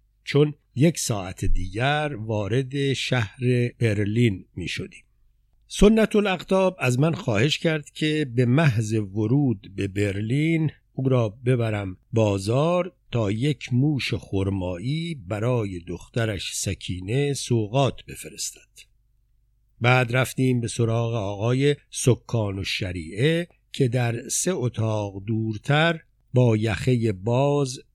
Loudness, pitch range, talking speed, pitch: -24 LUFS, 110-140 Hz, 105 wpm, 120 Hz